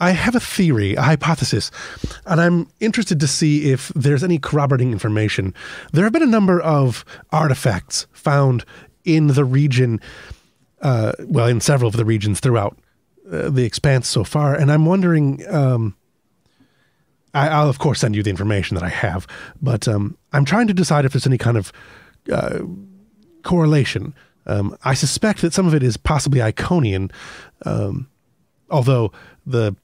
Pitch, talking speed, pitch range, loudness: 140 Hz, 165 wpm, 115-160 Hz, -18 LUFS